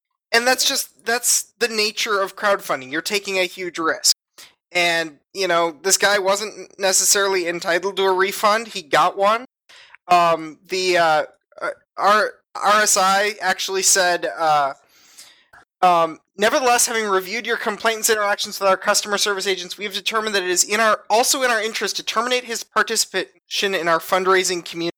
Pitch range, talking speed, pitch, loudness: 185-220 Hz, 160 wpm, 195 Hz, -19 LUFS